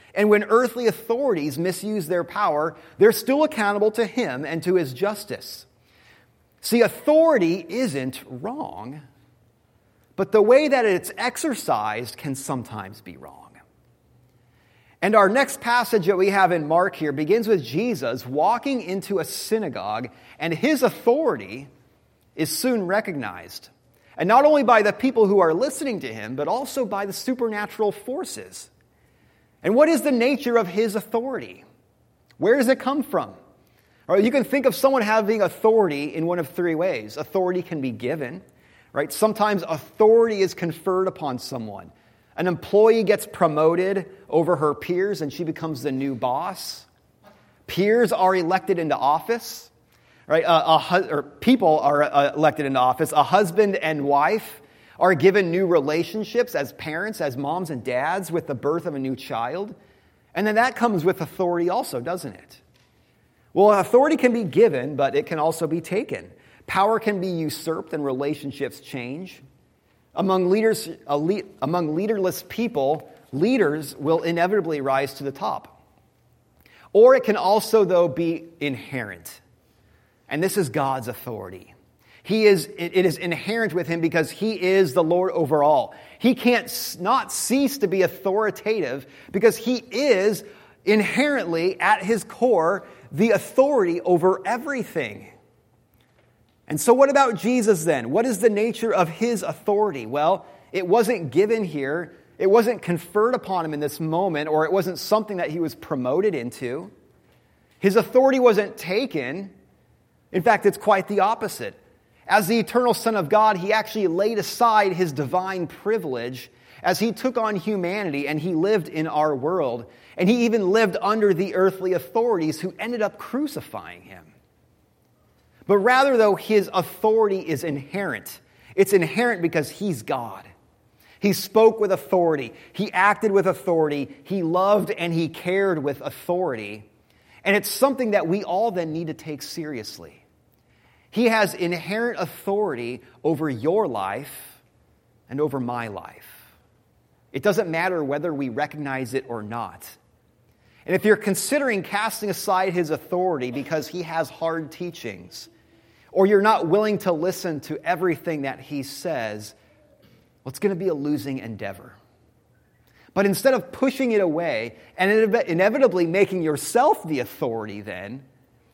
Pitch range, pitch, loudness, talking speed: 150-215 Hz, 180 Hz, -22 LUFS, 150 wpm